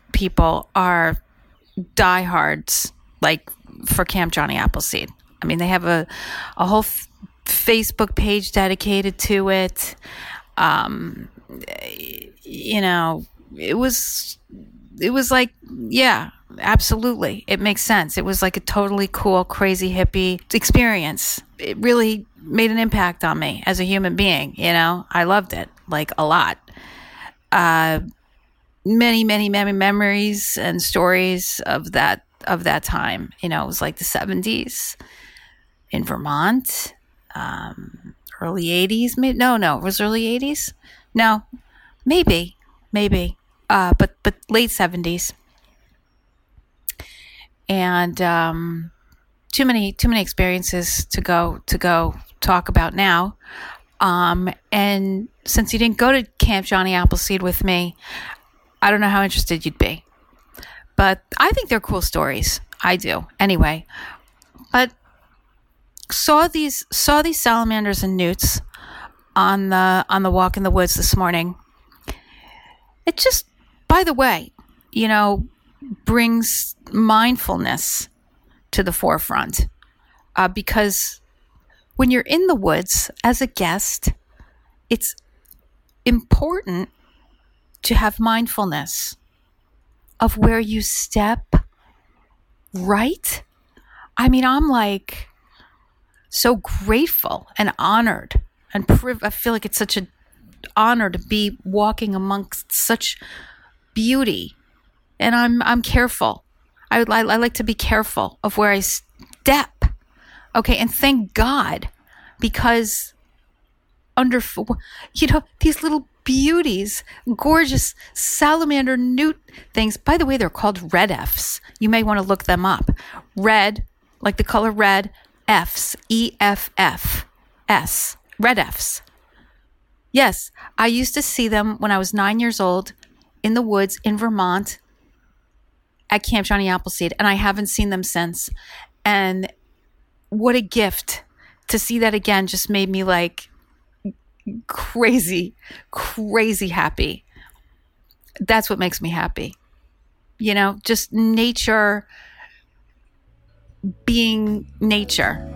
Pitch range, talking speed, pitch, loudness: 185-230 Hz, 125 wpm, 205 Hz, -19 LUFS